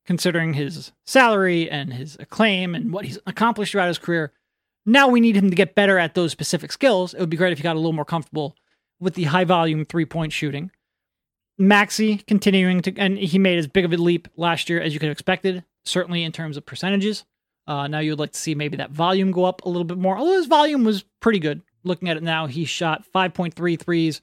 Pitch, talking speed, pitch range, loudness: 175 Hz, 235 wpm, 160-195 Hz, -20 LUFS